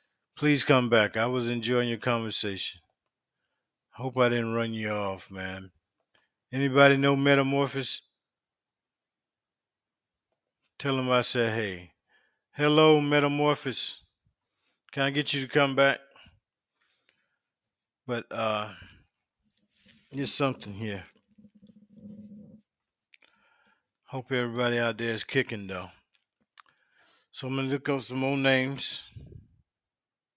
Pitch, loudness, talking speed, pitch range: 130 Hz, -27 LUFS, 105 wpm, 115-140 Hz